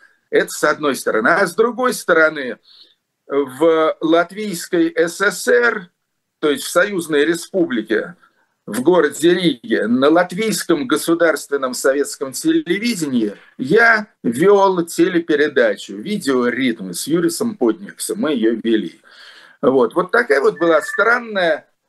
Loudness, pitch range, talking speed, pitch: -17 LUFS, 155-220 Hz, 110 wpm, 175 Hz